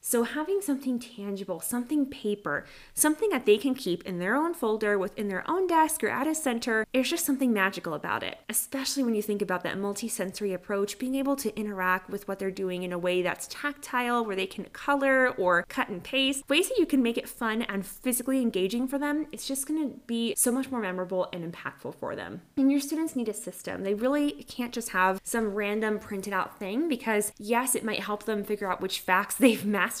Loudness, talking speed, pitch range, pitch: -28 LUFS, 220 wpm, 195-265 Hz, 220 Hz